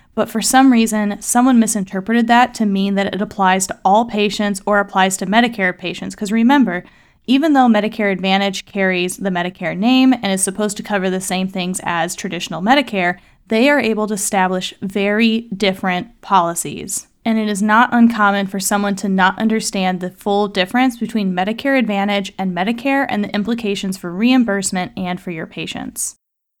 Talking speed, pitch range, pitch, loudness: 170 wpm, 190-225 Hz, 205 Hz, -16 LUFS